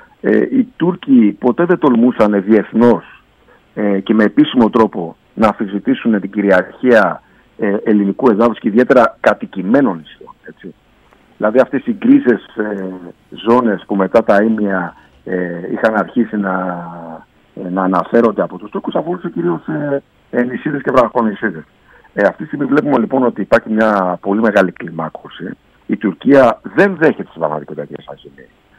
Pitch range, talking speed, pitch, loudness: 95-125 Hz, 135 wpm, 105 Hz, -14 LUFS